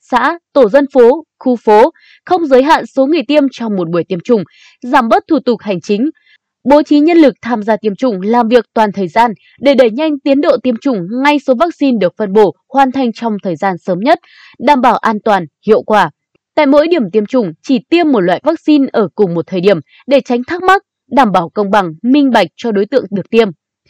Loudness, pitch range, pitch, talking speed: -12 LUFS, 210-290 Hz, 245 Hz, 230 wpm